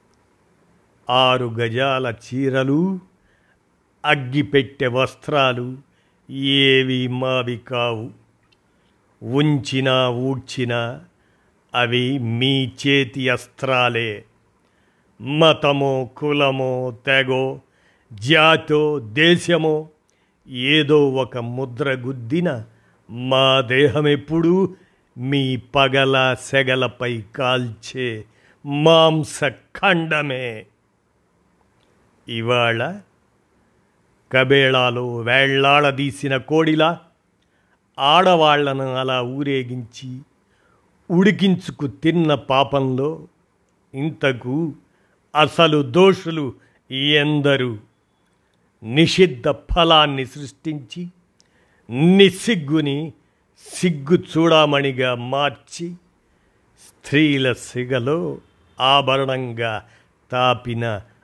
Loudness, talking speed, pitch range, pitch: -18 LUFS, 55 wpm, 125-150 Hz, 135 Hz